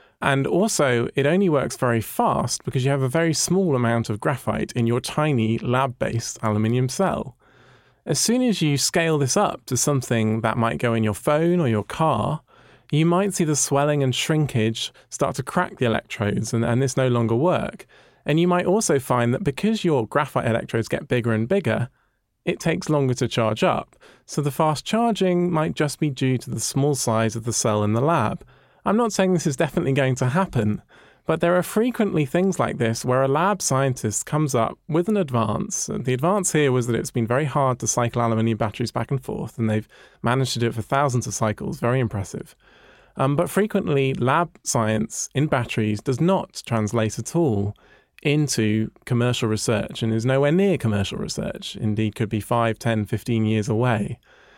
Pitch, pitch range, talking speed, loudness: 130 Hz, 115-155 Hz, 200 wpm, -22 LUFS